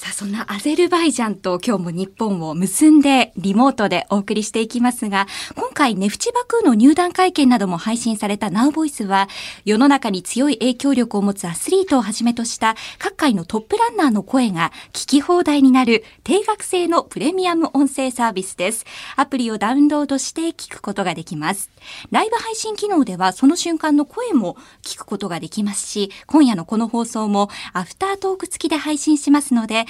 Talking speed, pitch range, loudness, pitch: 405 characters per minute, 205-305 Hz, -18 LUFS, 245 Hz